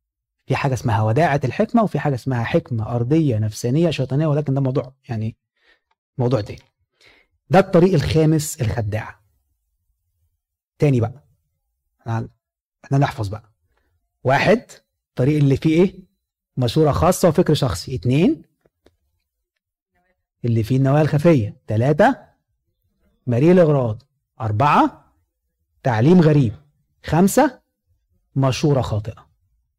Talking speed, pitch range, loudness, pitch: 100 wpm, 100-150 Hz, -19 LUFS, 125 Hz